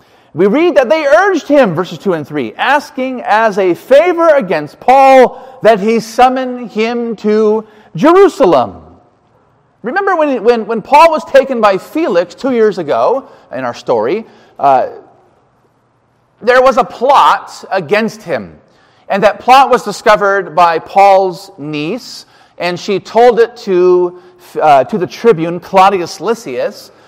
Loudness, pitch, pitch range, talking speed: -11 LUFS, 220 Hz, 180-265 Hz, 140 wpm